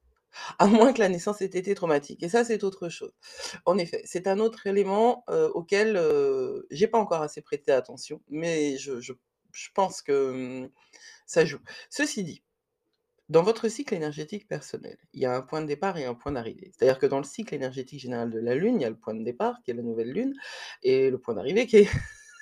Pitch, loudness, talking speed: 205 Hz, -27 LUFS, 220 wpm